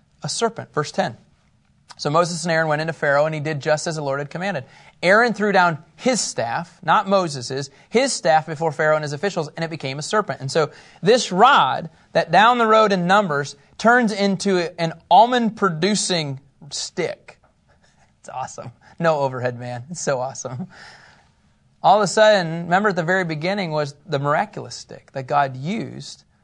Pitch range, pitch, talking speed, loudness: 145-195 Hz, 165 Hz, 180 wpm, -20 LUFS